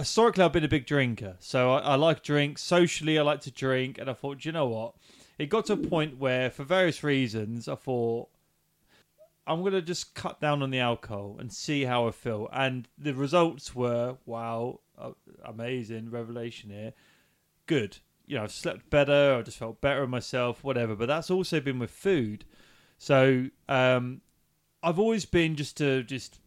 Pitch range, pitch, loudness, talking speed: 120-150 Hz, 135 Hz, -28 LUFS, 190 wpm